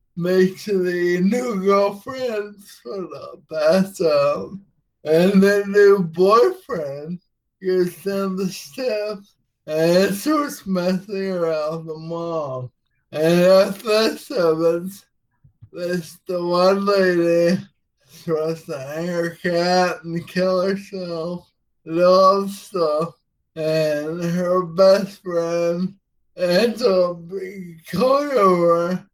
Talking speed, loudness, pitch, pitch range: 100 wpm, -19 LUFS, 180 Hz, 165-195 Hz